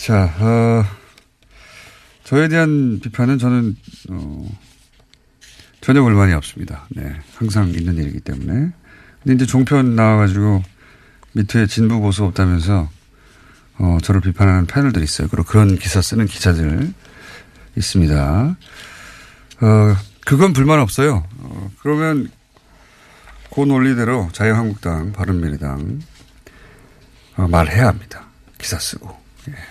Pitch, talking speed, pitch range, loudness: 105 Hz, 240 characters per minute, 95-130 Hz, -16 LUFS